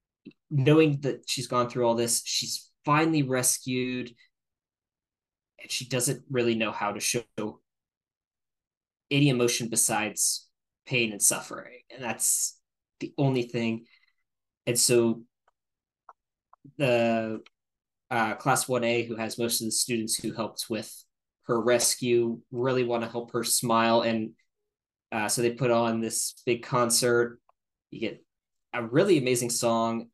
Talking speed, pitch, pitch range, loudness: 135 wpm, 120 Hz, 115-125 Hz, -26 LUFS